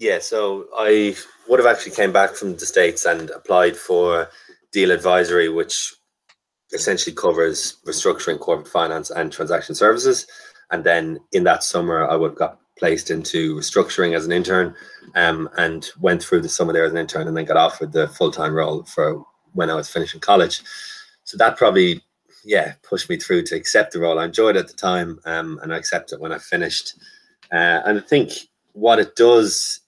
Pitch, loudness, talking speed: 355 Hz, -19 LUFS, 190 wpm